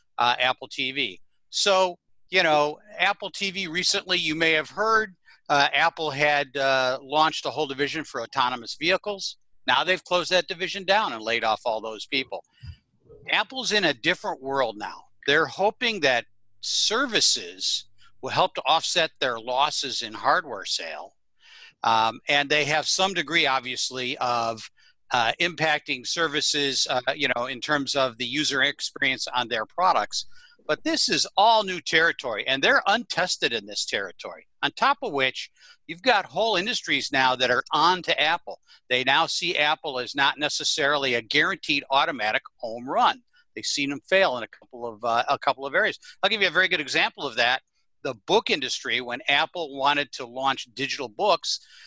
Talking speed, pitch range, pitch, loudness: 175 wpm, 130-180 Hz, 145 Hz, -23 LUFS